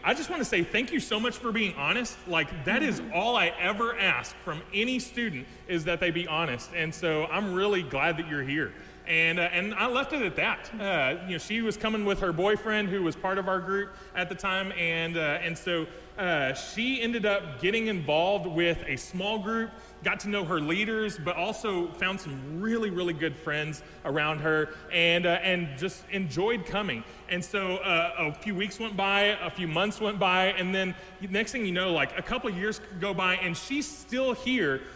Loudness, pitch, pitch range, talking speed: -28 LUFS, 185 Hz, 170-210 Hz, 215 wpm